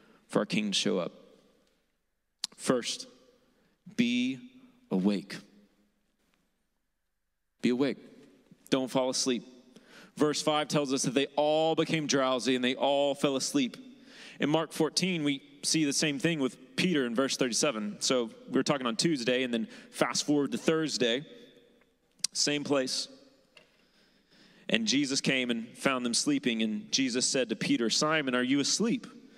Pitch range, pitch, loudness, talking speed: 130-205 Hz, 145 Hz, -29 LUFS, 145 wpm